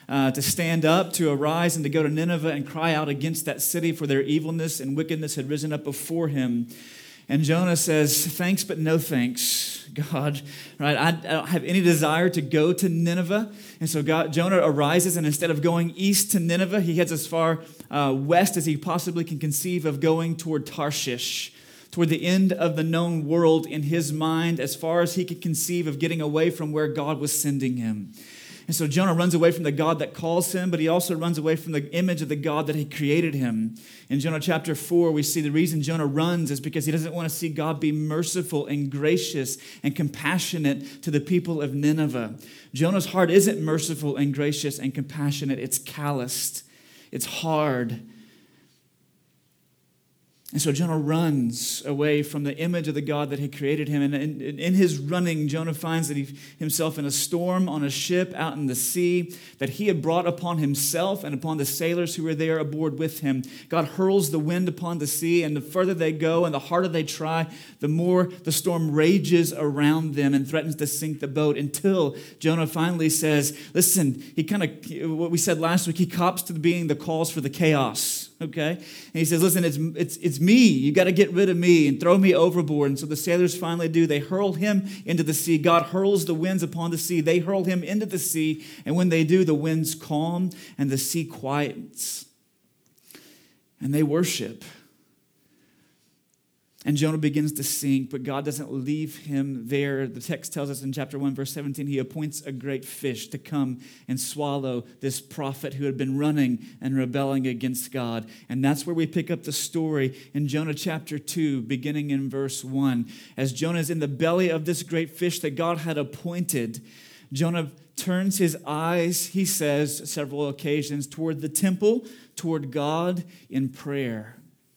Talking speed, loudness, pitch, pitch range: 200 wpm, -24 LUFS, 155 Hz, 145-170 Hz